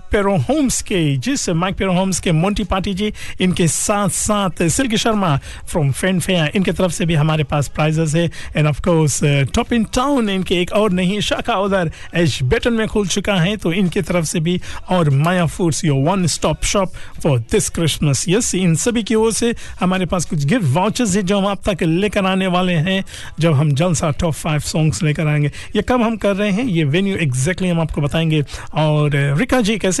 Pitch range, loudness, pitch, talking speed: 155-205 Hz, -17 LUFS, 180 Hz, 210 wpm